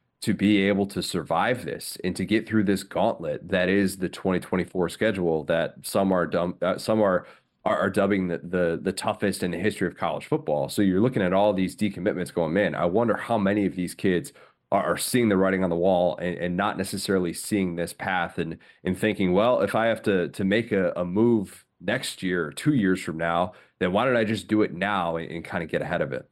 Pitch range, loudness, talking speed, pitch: 90-105 Hz, -25 LUFS, 235 wpm, 95 Hz